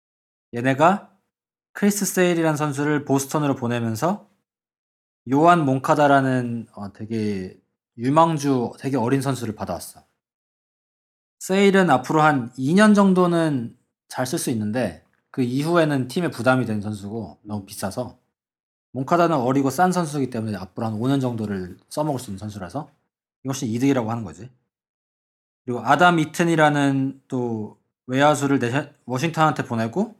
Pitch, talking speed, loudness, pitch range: 135 Hz, 300 characters per minute, -21 LUFS, 115-155 Hz